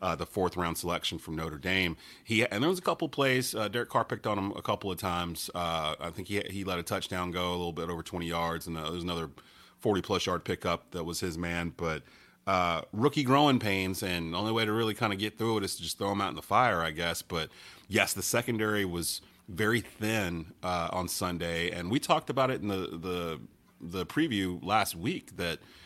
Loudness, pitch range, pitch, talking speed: -31 LUFS, 85-105 Hz, 90 Hz, 240 wpm